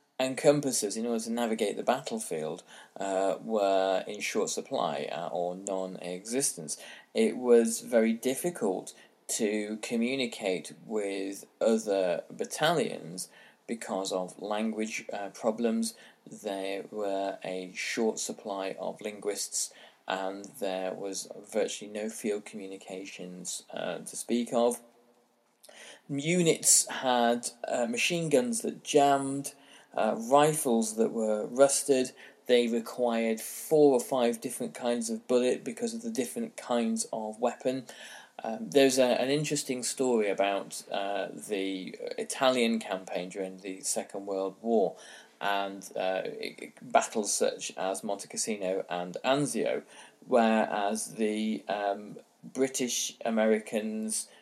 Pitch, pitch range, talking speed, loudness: 115 Hz, 100-130 Hz, 120 wpm, -30 LUFS